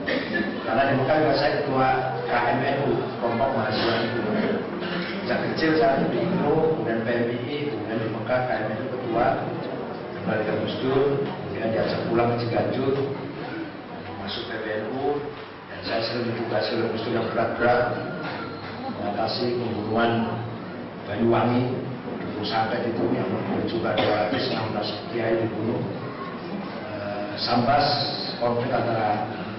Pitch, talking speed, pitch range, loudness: 120 Hz, 120 wpm, 110-135 Hz, -25 LUFS